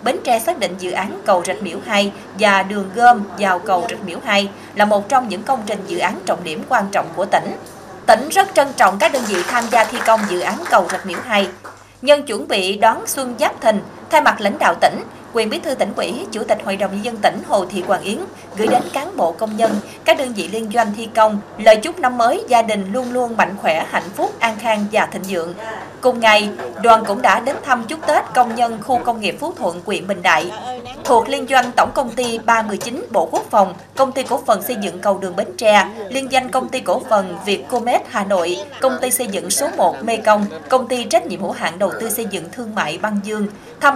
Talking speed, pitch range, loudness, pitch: 245 wpm, 200-250 Hz, -17 LUFS, 225 Hz